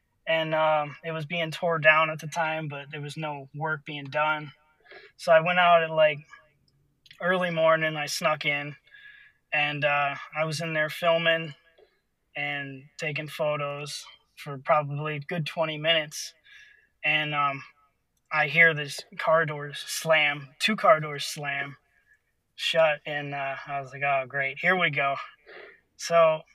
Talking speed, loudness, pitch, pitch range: 155 wpm, -25 LUFS, 155 Hz, 145-165 Hz